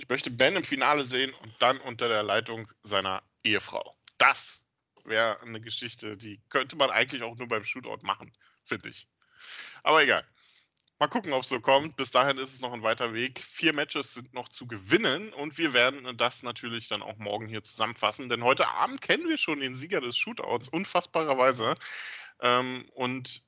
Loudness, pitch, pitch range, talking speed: -28 LUFS, 125 Hz, 115-135 Hz, 185 wpm